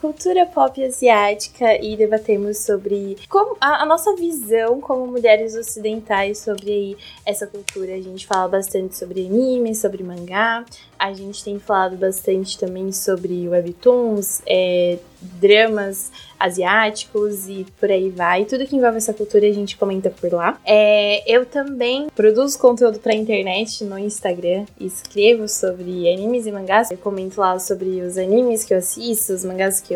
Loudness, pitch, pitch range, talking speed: -18 LUFS, 205 Hz, 190-230 Hz, 155 wpm